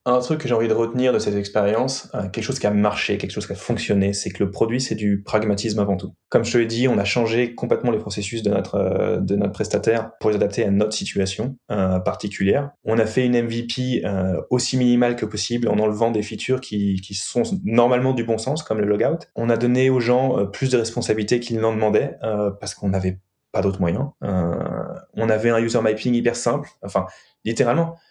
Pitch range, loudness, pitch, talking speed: 100-120 Hz, -21 LUFS, 110 Hz, 220 wpm